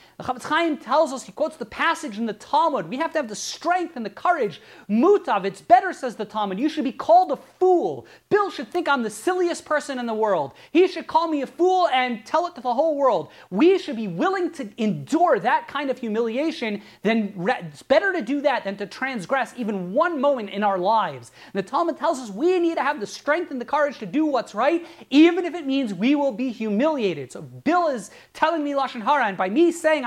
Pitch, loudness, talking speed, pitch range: 280 Hz, -22 LUFS, 235 wpm, 225-325 Hz